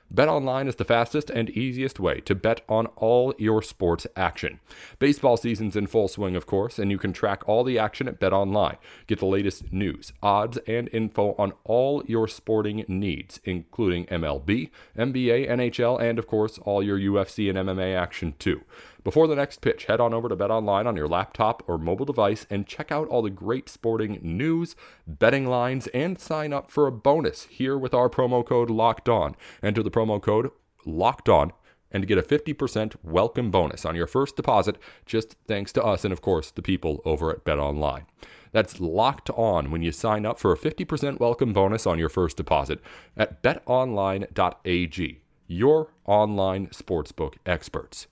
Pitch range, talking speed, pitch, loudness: 95-125 Hz, 180 wpm, 110 Hz, -25 LUFS